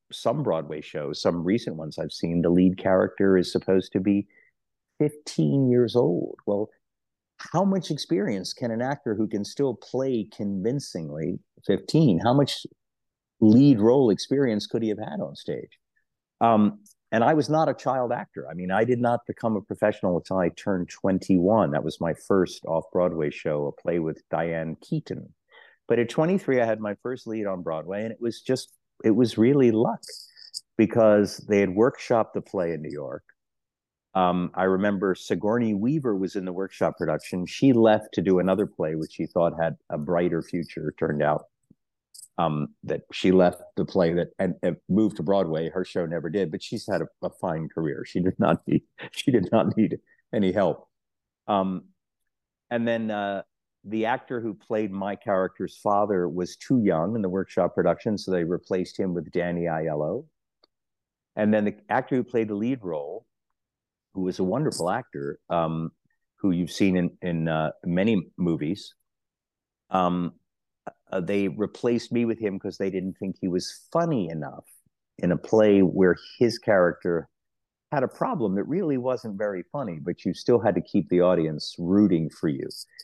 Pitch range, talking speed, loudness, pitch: 90-115 Hz, 180 wpm, -25 LUFS, 100 Hz